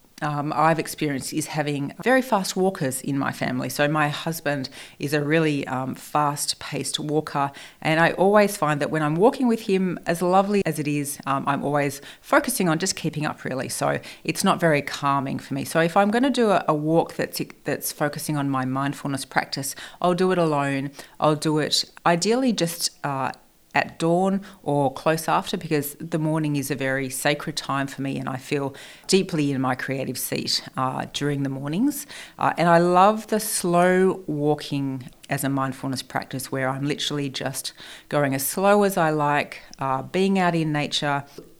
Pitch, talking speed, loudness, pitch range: 150 Hz, 190 wpm, -23 LUFS, 140-170 Hz